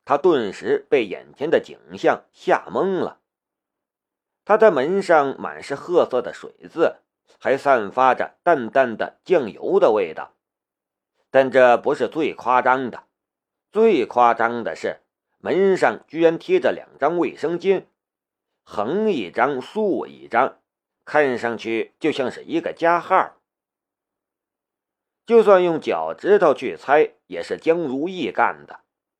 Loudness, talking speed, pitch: -20 LUFS, 185 characters per minute, 195 Hz